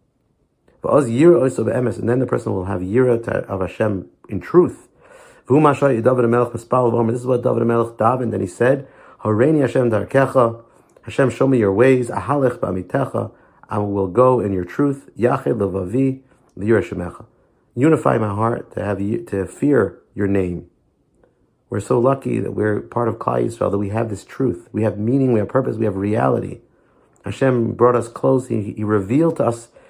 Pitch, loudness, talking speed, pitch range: 115 Hz, -18 LUFS, 150 wpm, 105-130 Hz